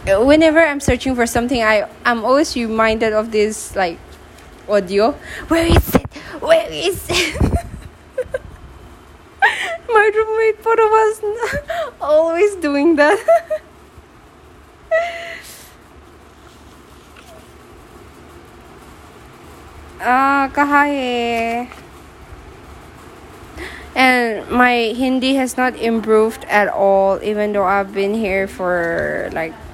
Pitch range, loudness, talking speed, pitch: 220-330 Hz, -16 LUFS, 85 wpm, 260 Hz